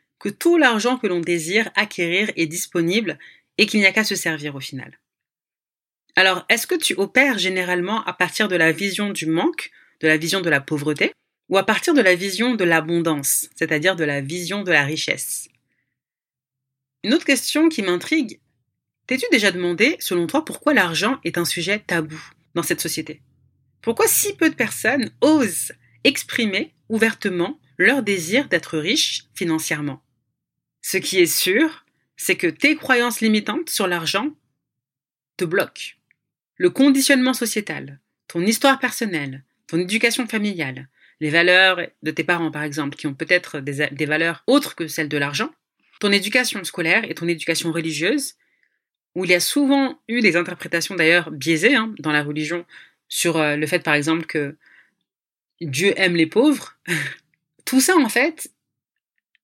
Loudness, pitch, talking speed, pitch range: -19 LUFS, 180 Hz, 160 wpm, 160-235 Hz